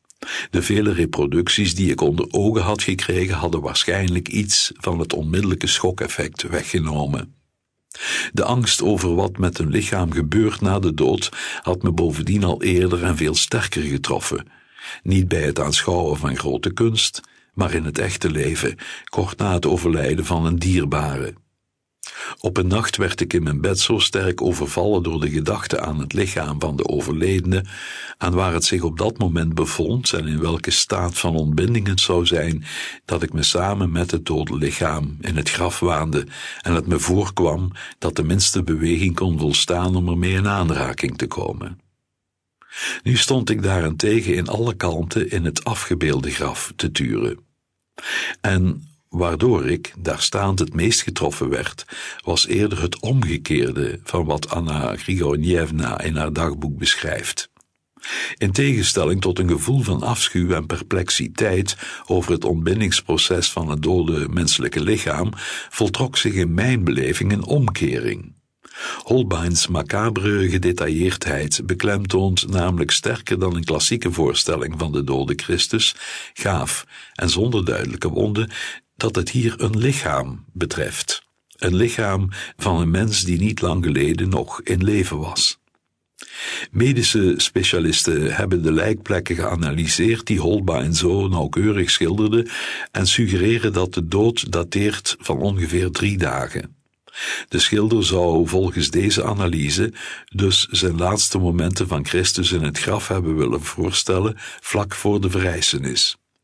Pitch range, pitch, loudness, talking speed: 85-100 Hz, 90 Hz, -20 LUFS, 145 wpm